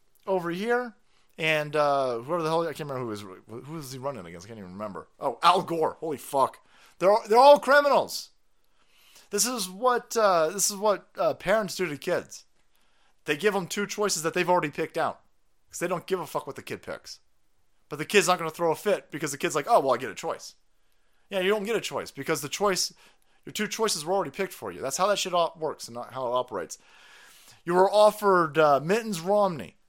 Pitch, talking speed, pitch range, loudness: 180 Hz, 230 wpm, 145-205 Hz, -26 LUFS